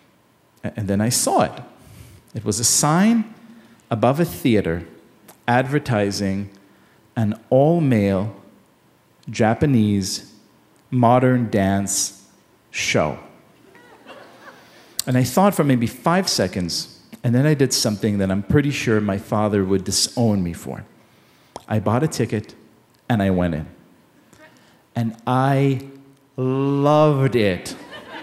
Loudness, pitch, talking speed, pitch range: -20 LUFS, 115 Hz, 115 wpm, 100-135 Hz